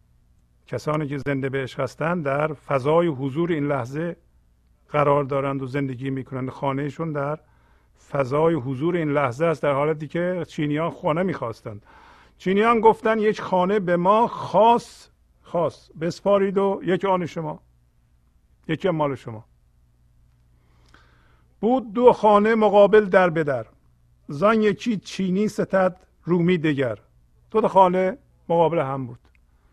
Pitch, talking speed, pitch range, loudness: 150 Hz, 130 wpm, 115-185 Hz, -22 LUFS